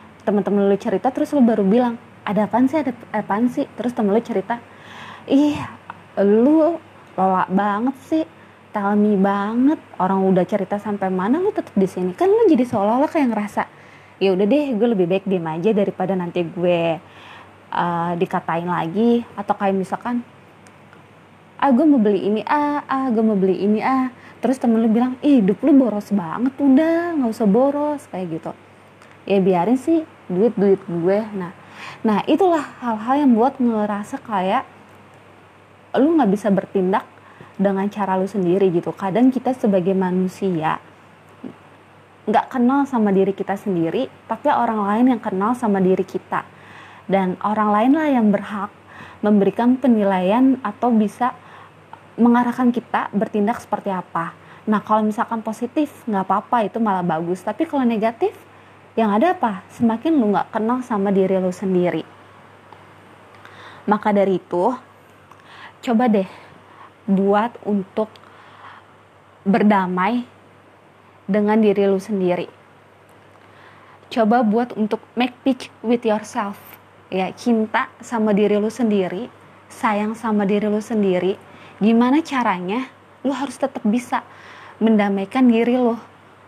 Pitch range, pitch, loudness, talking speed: 195-245 Hz, 215 Hz, -19 LUFS, 140 wpm